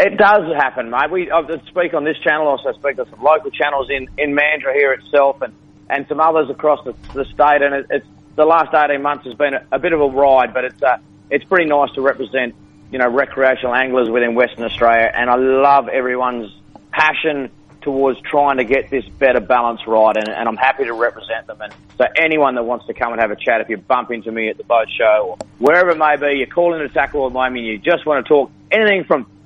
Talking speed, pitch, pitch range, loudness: 245 wpm, 140 Hz, 125-150 Hz, -16 LUFS